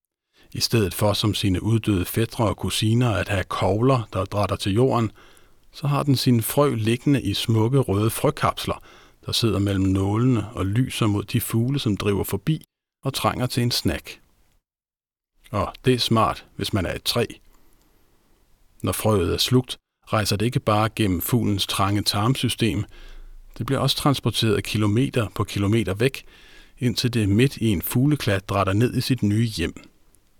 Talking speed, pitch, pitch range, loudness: 165 wpm, 110 Hz, 100-125 Hz, -22 LUFS